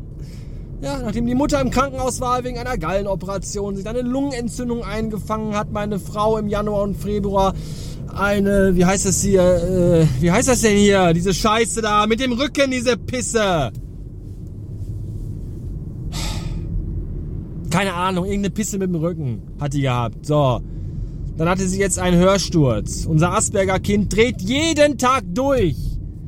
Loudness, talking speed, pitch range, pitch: -19 LUFS, 145 wpm, 155-220 Hz, 195 Hz